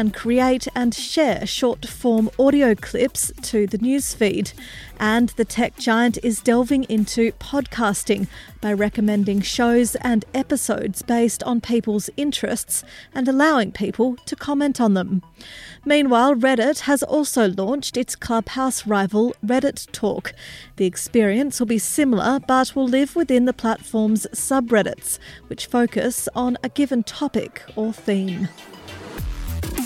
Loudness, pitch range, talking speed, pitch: -20 LUFS, 215-265 Hz, 130 wpm, 235 Hz